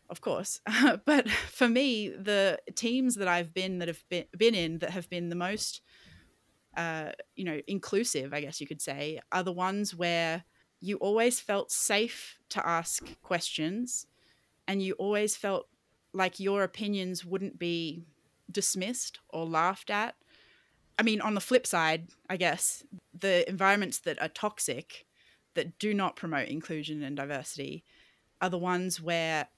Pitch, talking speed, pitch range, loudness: 185 Hz, 160 wpm, 170-205 Hz, -31 LUFS